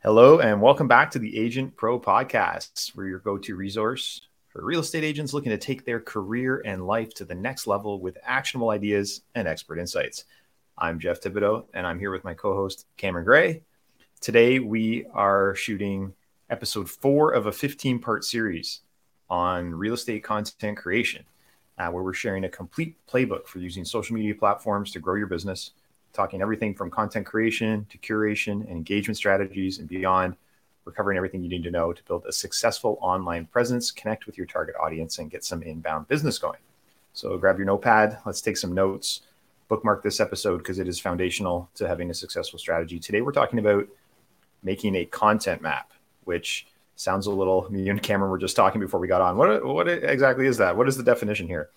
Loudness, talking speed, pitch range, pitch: -25 LUFS, 190 wpm, 95-115 Hz, 100 Hz